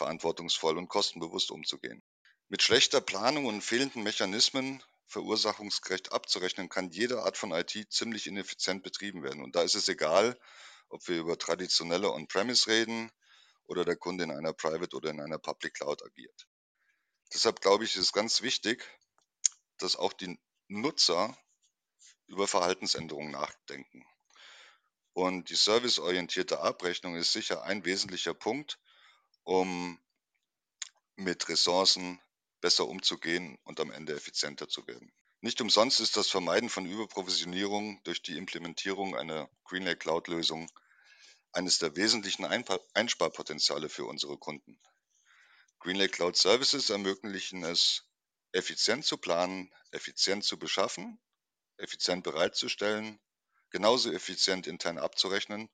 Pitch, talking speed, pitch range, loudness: 100 Hz, 120 wpm, 90-110 Hz, -30 LUFS